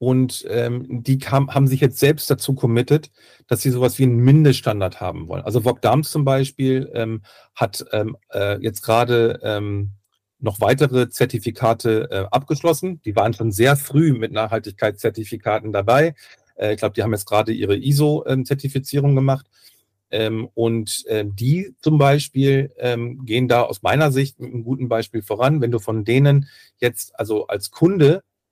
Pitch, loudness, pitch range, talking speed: 125 Hz, -19 LUFS, 110-135 Hz, 165 wpm